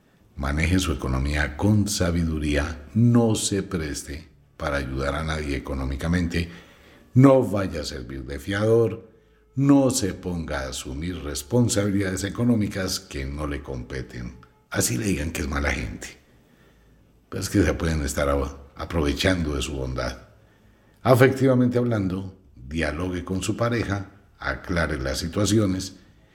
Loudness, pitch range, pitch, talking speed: -24 LUFS, 70-100 Hz, 85 Hz, 125 wpm